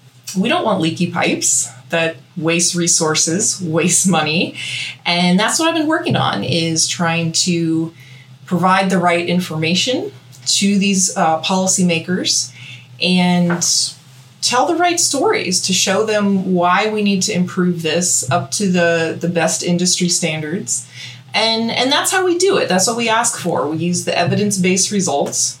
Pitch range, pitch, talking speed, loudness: 160-190 Hz, 175 Hz, 155 wpm, -15 LUFS